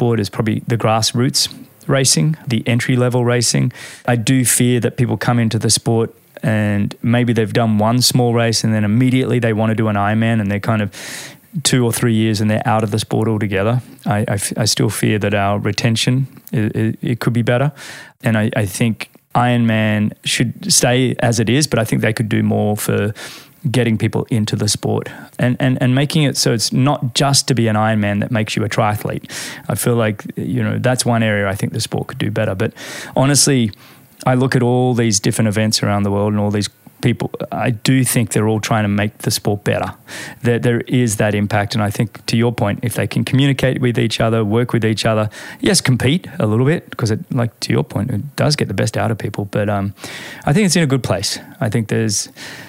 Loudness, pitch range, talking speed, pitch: -16 LUFS, 110-125 Hz, 225 wpm, 115 Hz